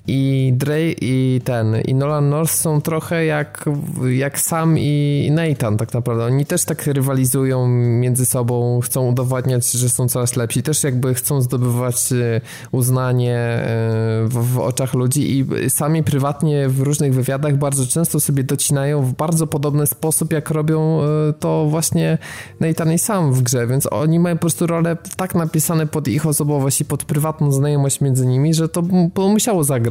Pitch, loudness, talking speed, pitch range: 140 Hz, -17 LUFS, 165 wpm, 130-155 Hz